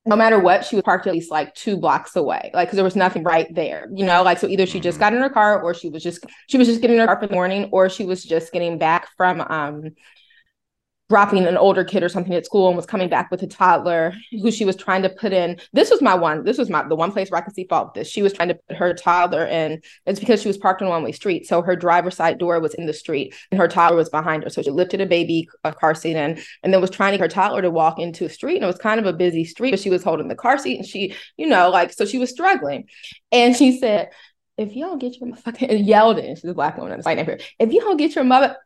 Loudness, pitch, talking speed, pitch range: -19 LUFS, 185 Hz, 300 wpm, 170-210 Hz